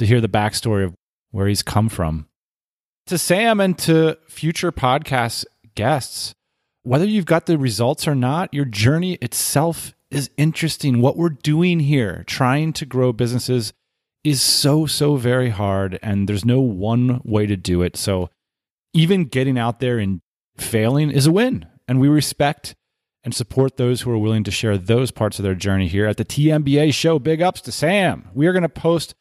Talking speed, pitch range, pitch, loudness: 185 wpm, 110-155 Hz, 130 Hz, -19 LUFS